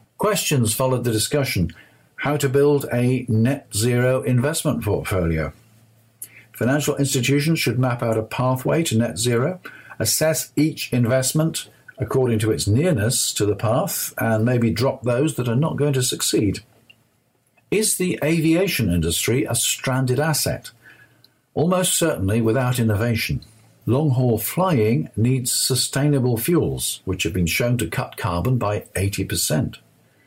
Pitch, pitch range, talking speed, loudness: 125 Hz, 110-140 Hz, 135 wpm, -20 LUFS